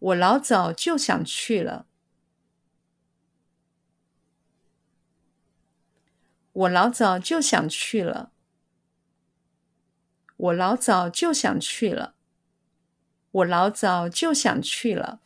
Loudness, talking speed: -23 LUFS, 110 characters per minute